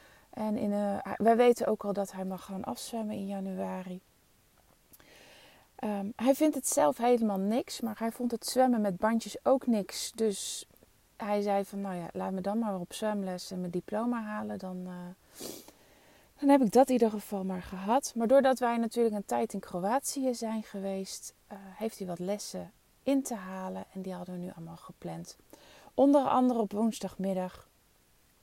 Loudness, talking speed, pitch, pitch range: -31 LUFS, 180 wpm, 210 Hz, 190-235 Hz